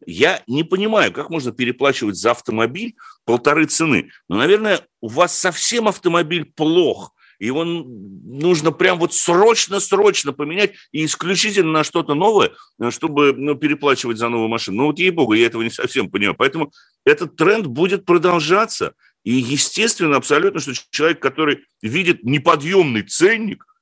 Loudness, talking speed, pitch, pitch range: -17 LUFS, 145 wpm, 170 Hz, 145-195 Hz